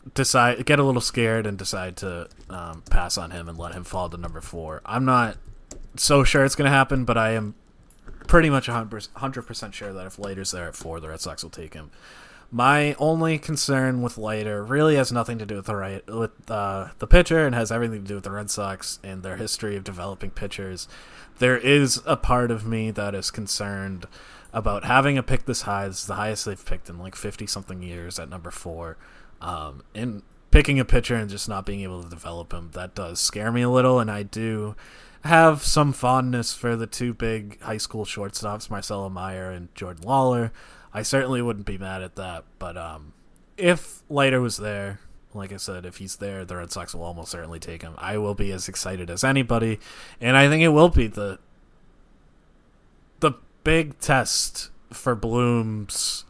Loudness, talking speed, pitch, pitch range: -23 LUFS, 205 wpm, 105 Hz, 95-120 Hz